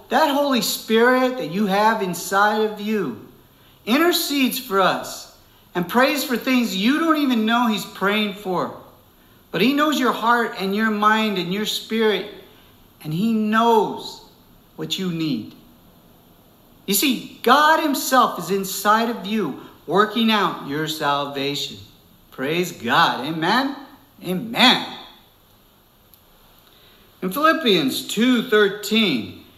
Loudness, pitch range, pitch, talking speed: -20 LUFS, 185-250 Hz, 215 Hz, 120 wpm